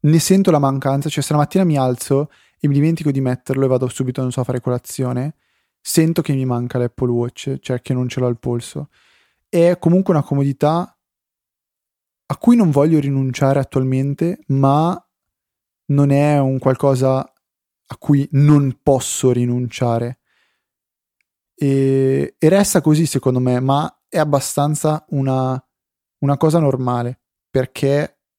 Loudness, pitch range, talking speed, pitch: -17 LUFS, 125-150 Hz, 145 wpm, 135 Hz